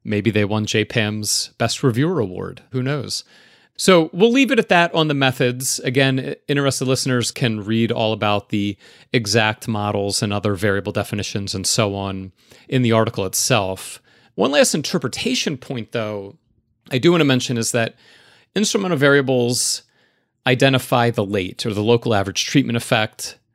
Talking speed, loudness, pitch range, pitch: 160 wpm, -19 LUFS, 105-135 Hz, 120 Hz